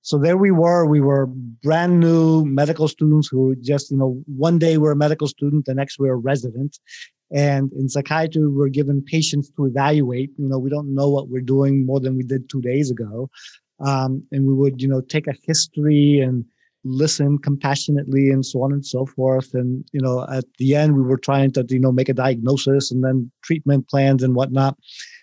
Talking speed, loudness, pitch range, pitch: 210 wpm, -19 LUFS, 130-150 Hz, 140 Hz